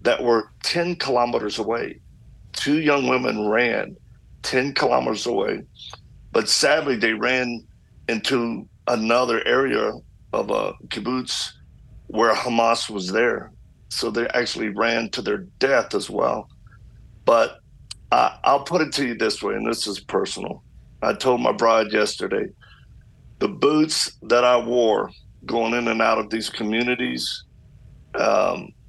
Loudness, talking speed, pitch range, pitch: -22 LUFS, 135 wpm, 110-130 Hz, 120 Hz